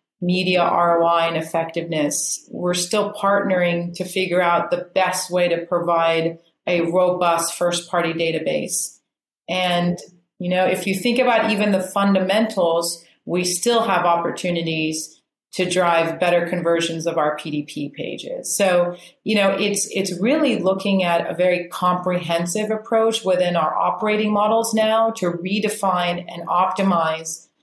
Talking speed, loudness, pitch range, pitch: 135 wpm, -20 LUFS, 170-195 Hz, 180 Hz